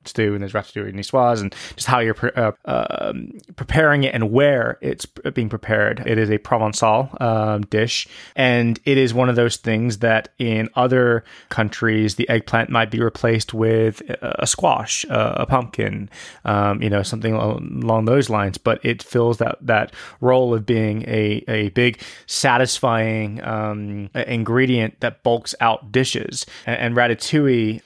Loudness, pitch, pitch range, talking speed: -19 LUFS, 115 Hz, 110-125 Hz, 165 wpm